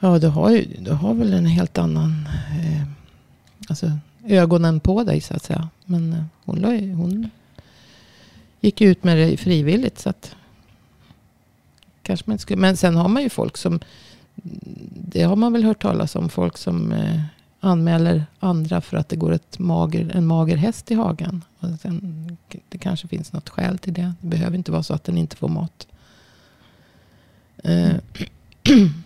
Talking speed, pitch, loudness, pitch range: 165 wpm, 175 Hz, -20 LUFS, 160-185 Hz